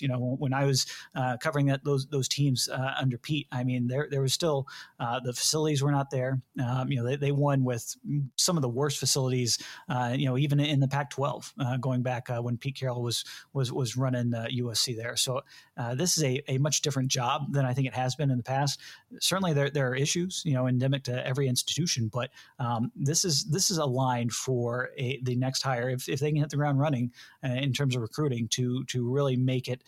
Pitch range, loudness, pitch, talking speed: 125-140 Hz, -29 LUFS, 130 Hz, 240 wpm